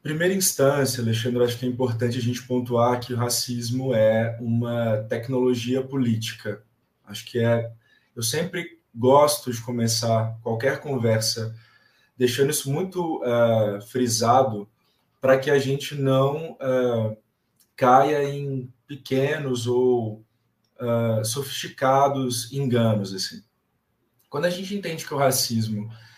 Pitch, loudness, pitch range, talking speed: 125 Hz, -23 LUFS, 115-135 Hz, 110 wpm